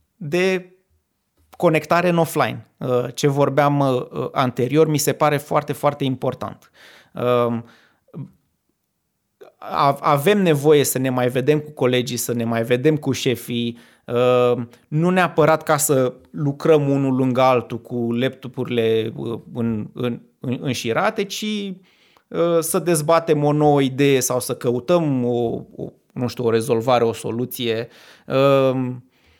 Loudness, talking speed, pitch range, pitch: -20 LUFS, 120 wpm, 120-155 Hz, 130 Hz